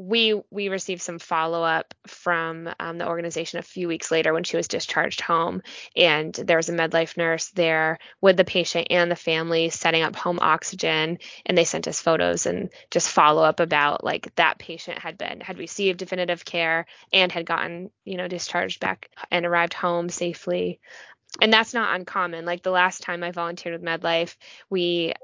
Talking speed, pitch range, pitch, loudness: 185 wpm, 165-180 Hz, 170 Hz, -23 LUFS